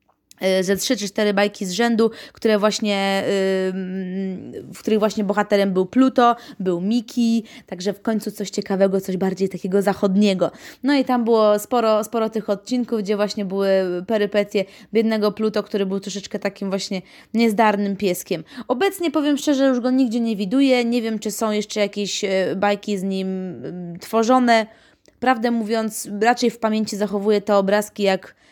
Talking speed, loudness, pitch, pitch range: 160 wpm, -20 LUFS, 210 Hz, 195-230 Hz